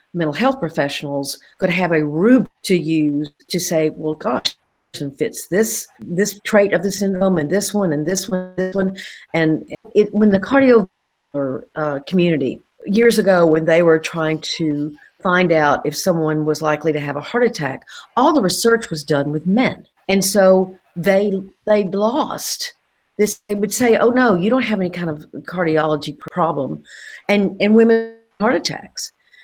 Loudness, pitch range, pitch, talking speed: -18 LUFS, 155-210 Hz, 185 Hz, 170 wpm